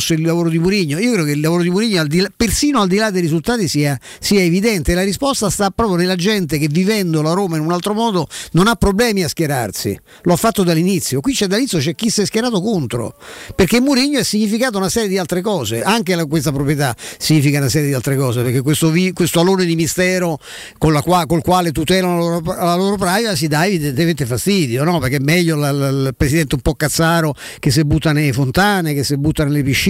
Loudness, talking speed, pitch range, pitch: -16 LUFS, 230 wpm, 155-195 Hz, 175 Hz